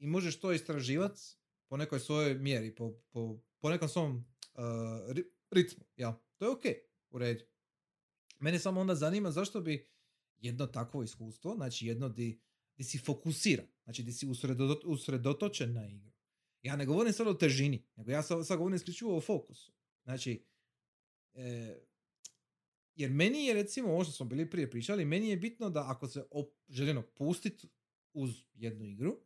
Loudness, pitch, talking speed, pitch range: -37 LUFS, 140 Hz, 165 wpm, 120-175 Hz